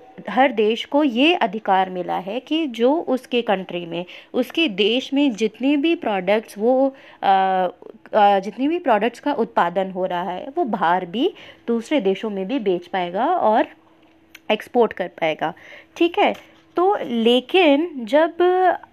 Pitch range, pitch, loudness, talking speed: 195-295 Hz, 235 Hz, -20 LUFS, 145 wpm